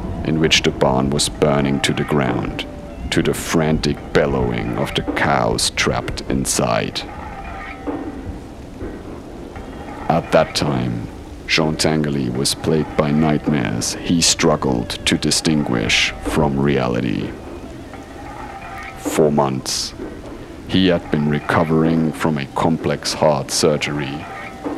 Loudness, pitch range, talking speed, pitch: -18 LUFS, 70-80 Hz, 105 wpm, 75 Hz